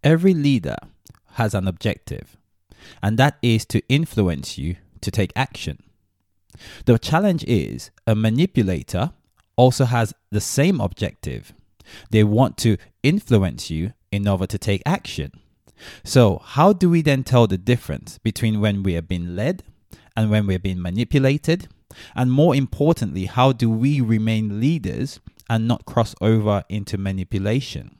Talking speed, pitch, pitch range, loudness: 145 wpm, 110 Hz, 95-130 Hz, -20 LUFS